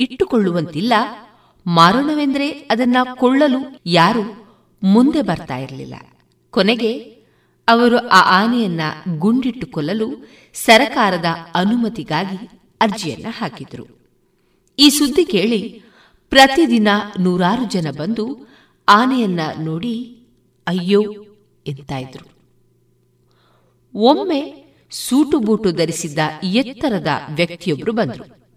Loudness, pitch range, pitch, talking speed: -16 LUFS, 170-245 Hz, 210 Hz, 75 wpm